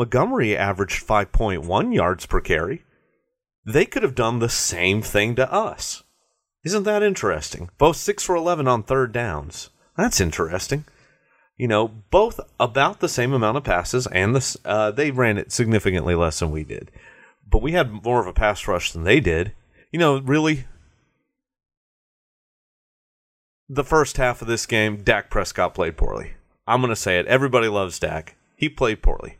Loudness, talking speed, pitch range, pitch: -21 LUFS, 165 wpm, 105-140 Hz, 120 Hz